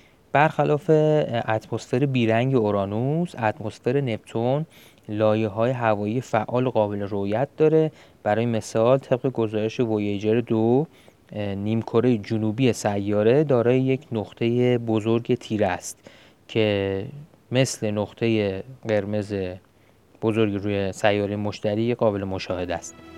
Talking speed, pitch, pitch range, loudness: 100 wpm, 110 Hz, 105-125 Hz, -23 LUFS